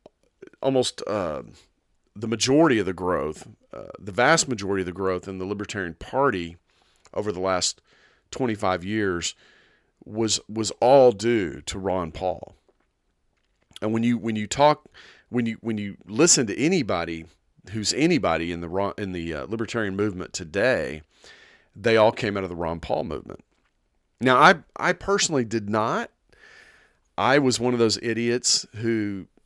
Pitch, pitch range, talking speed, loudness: 105 Hz, 95-115 Hz, 155 wpm, -23 LUFS